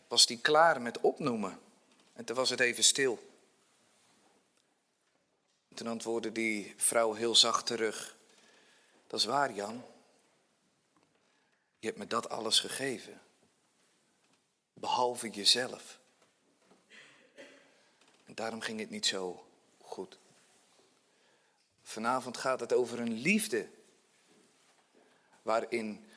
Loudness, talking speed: -30 LUFS, 105 wpm